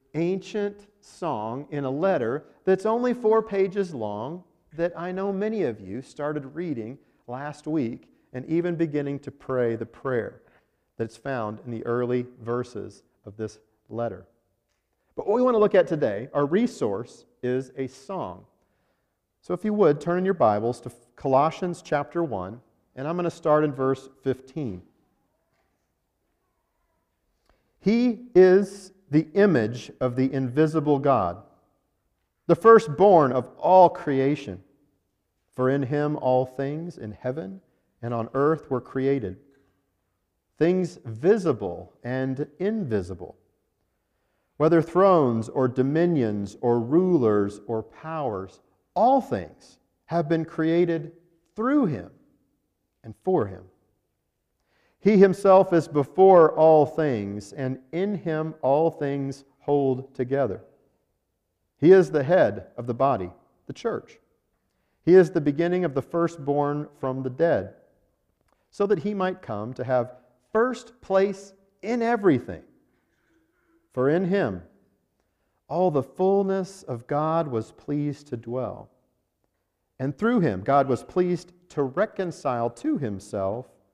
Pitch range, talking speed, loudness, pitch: 125-180 Hz, 130 wpm, -24 LUFS, 145 Hz